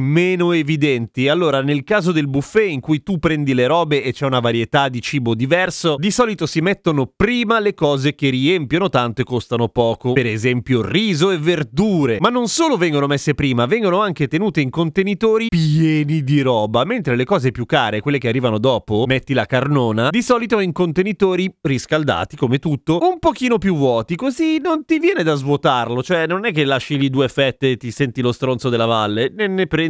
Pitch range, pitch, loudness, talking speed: 130-185 Hz, 150 Hz, -17 LUFS, 200 wpm